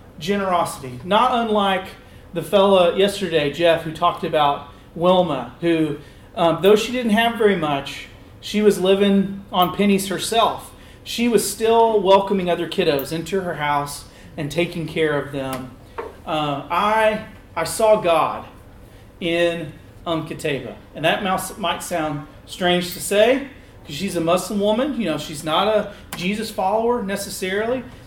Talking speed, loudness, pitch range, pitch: 145 wpm, -20 LUFS, 155-200 Hz, 175 Hz